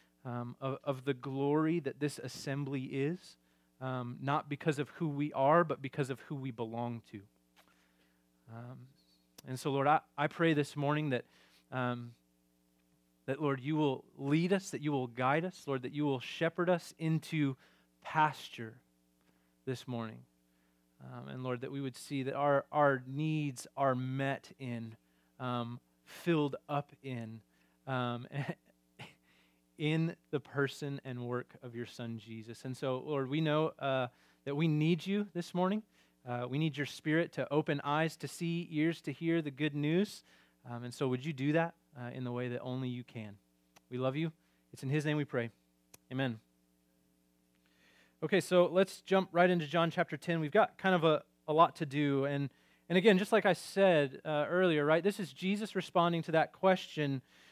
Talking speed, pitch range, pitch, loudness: 180 wpm, 115-155 Hz, 135 Hz, -34 LUFS